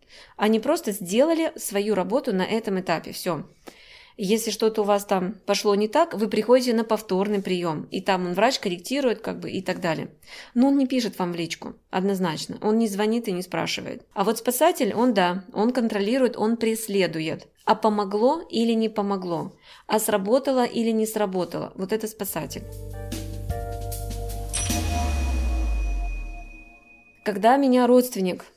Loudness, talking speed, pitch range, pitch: -24 LUFS, 150 wpm, 175-230 Hz, 205 Hz